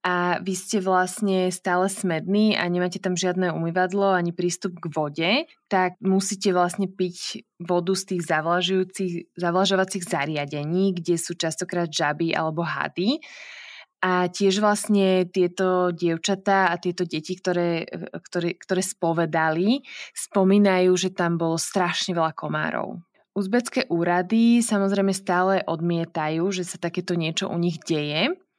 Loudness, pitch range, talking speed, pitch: -23 LUFS, 170-195 Hz, 130 wpm, 180 Hz